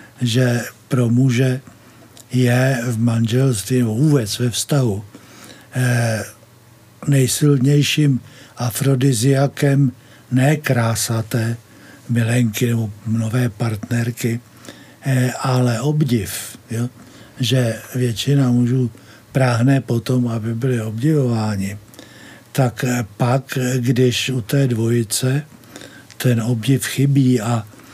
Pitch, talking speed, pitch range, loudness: 125 Hz, 80 wpm, 115-130 Hz, -18 LUFS